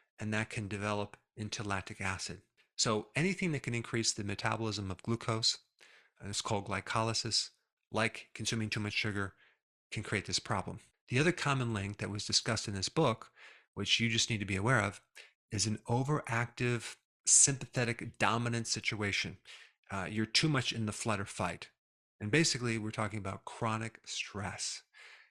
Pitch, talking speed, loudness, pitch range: 110 Hz, 160 wpm, -34 LUFS, 105-120 Hz